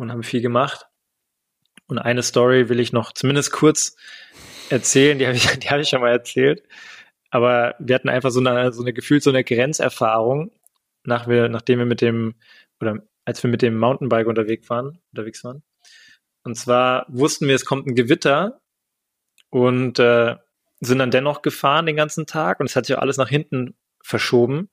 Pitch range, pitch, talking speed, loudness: 120-140 Hz, 125 Hz, 180 wpm, -19 LUFS